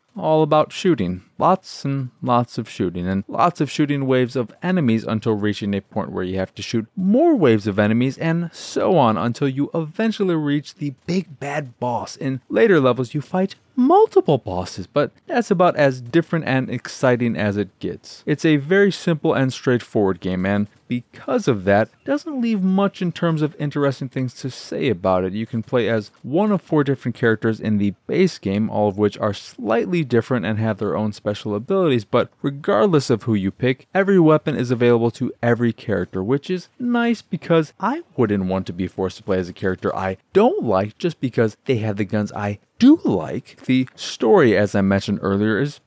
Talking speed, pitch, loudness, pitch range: 200 wpm, 125 Hz, -20 LUFS, 105-165 Hz